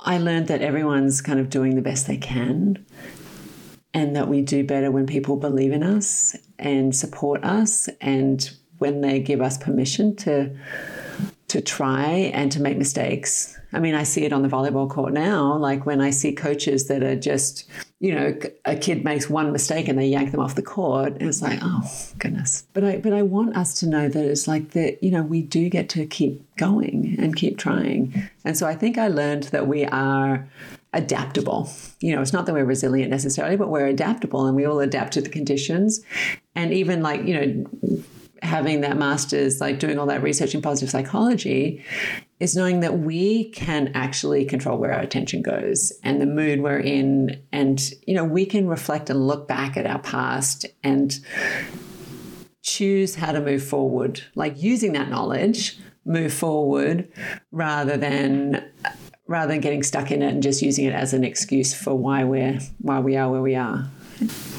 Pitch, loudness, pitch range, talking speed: 145 Hz, -22 LUFS, 135-170 Hz, 190 wpm